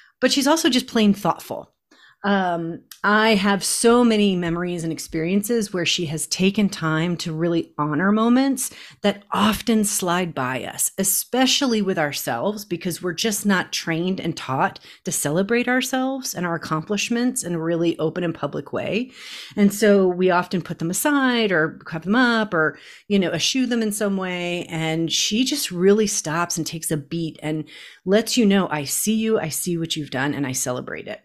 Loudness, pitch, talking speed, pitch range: -21 LUFS, 185 Hz, 180 wpm, 165-215 Hz